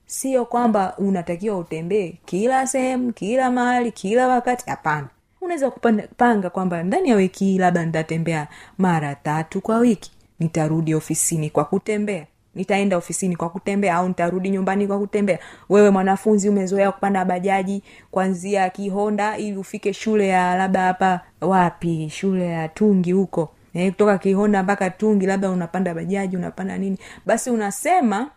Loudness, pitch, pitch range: -21 LUFS, 195 Hz, 180-210 Hz